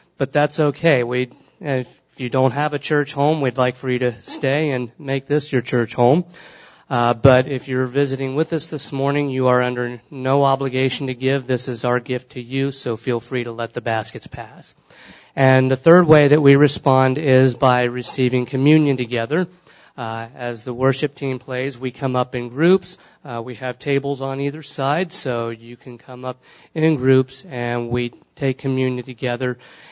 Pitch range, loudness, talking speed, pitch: 125-140 Hz, -19 LUFS, 190 wpm, 130 Hz